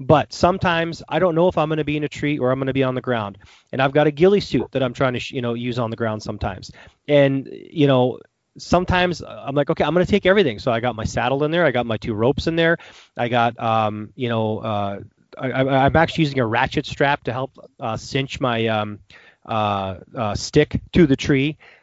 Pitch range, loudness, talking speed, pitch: 115-150 Hz, -20 LUFS, 245 wpm, 130 Hz